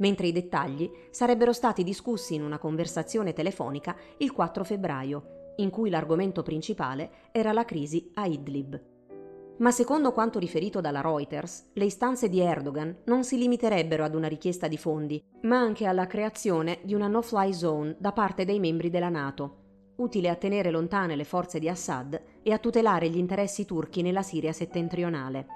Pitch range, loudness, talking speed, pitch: 160-210 Hz, -29 LUFS, 165 wpm, 175 Hz